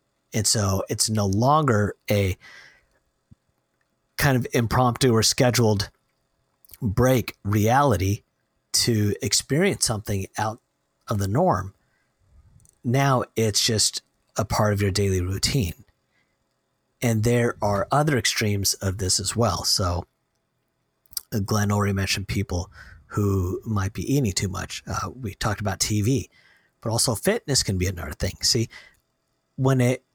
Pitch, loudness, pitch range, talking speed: 105 Hz, -23 LUFS, 100-120 Hz, 125 wpm